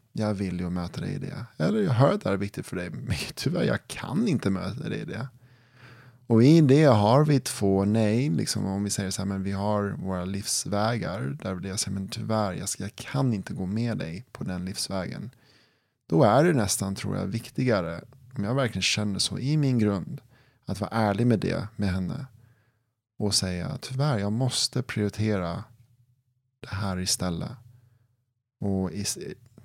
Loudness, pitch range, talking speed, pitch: -26 LUFS, 100-125 Hz, 190 wpm, 110 Hz